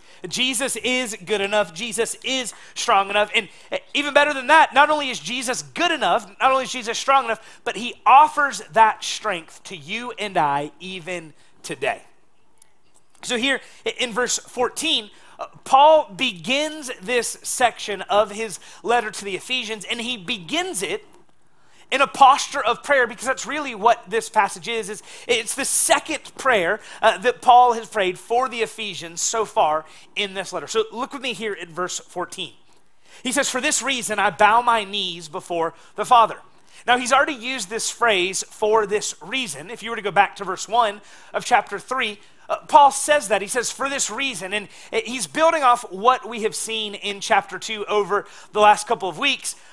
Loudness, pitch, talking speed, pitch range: -20 LUFS, 225 Hz, 185 wpm, 205-260 Hz